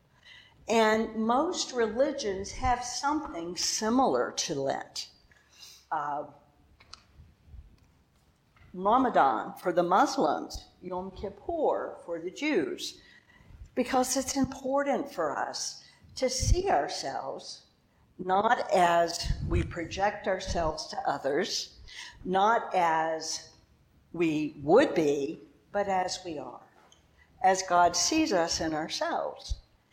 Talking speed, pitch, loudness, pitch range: 95 wpm, 195 Hz, -29 LUFS, 170-255 Hz